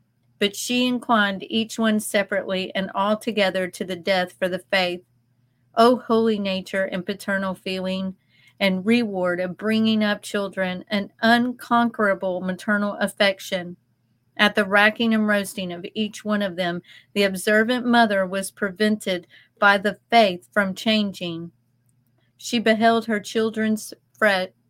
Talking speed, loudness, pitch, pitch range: 140 wpm, -22 LUFS, 200 Hz, 185-215 Hz